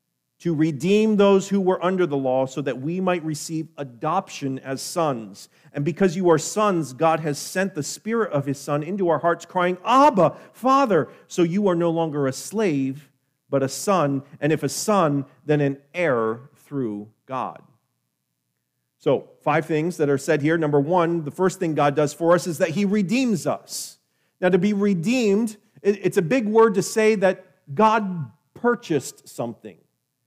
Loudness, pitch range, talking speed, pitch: -22 LUFS, 145-195 Hz, 175 wpm, 165 Hz